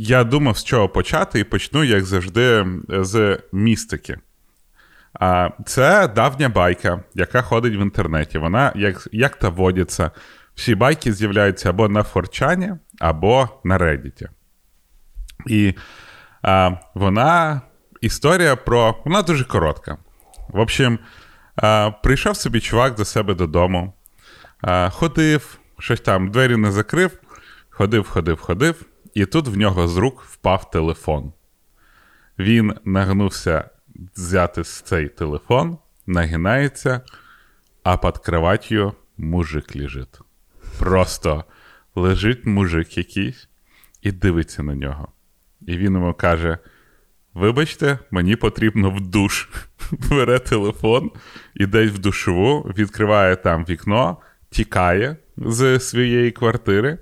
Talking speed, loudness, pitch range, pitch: 110 wpm, -19 LUFS, 90-120 Hz, 100 Hz